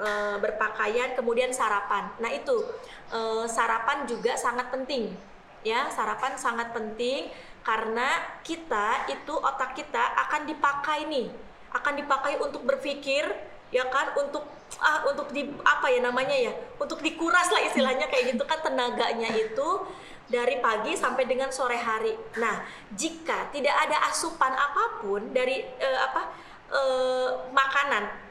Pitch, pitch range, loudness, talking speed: 280 Hz, 245-330 Hz, -27 LUFS, 130 wpm